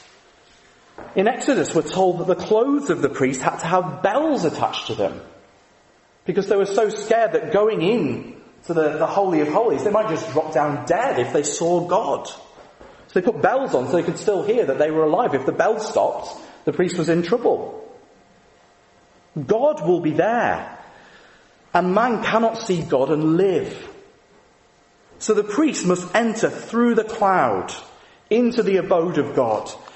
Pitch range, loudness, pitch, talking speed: 165-230 Hz, -20 LUFS, 195 Hz, 175 wpm